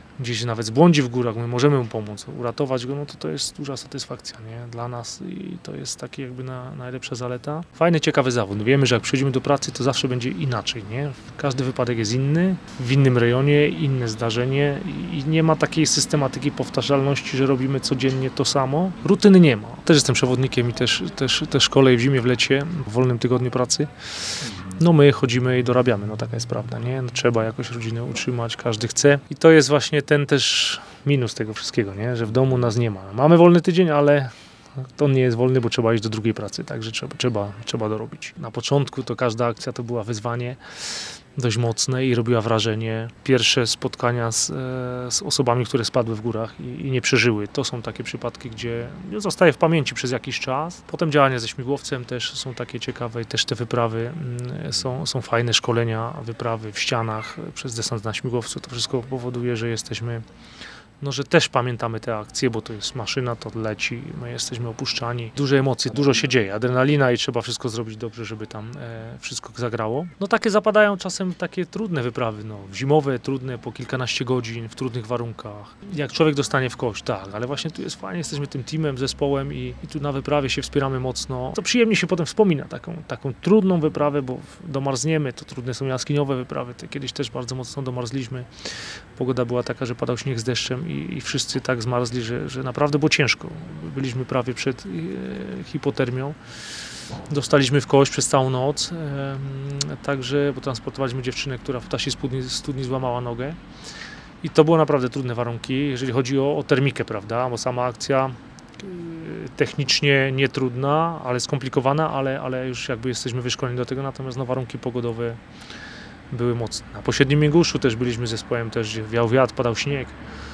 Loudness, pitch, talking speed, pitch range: -22 LUFS, 130 Hz, 185 wpm, 120-140 Hz